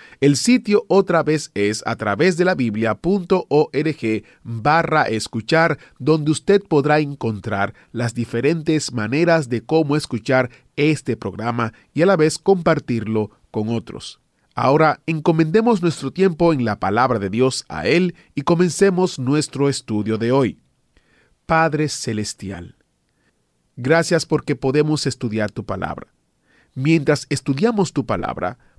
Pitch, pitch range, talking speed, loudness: 140 Hz, 115-160 Hz, 125 wpm, -19 LUFS